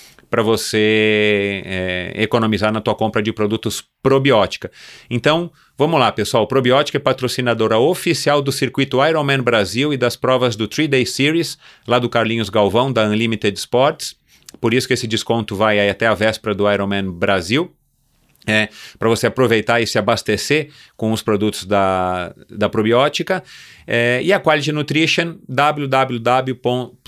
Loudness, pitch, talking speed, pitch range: -17 LUFS, 115 Hz, 150 wpm, 105-135 Hz